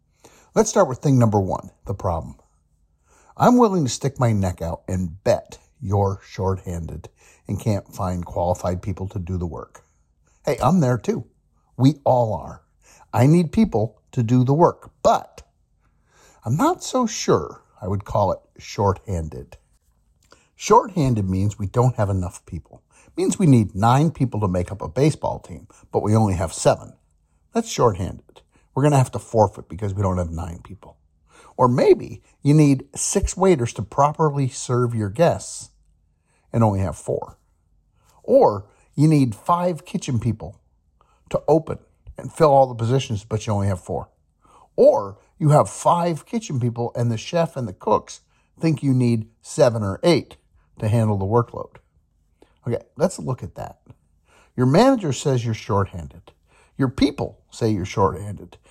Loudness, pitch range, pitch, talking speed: -21 LUFS, 90-135 Hz, 110 Hz, 165 wpm